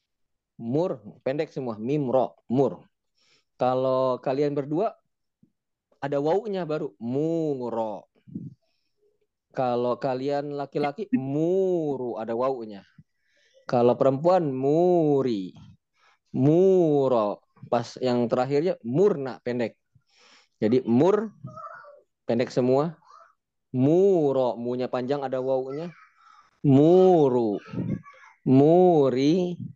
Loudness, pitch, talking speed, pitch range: -24 LUFS, 140 Hz, 80 wpm, 125-160 Hz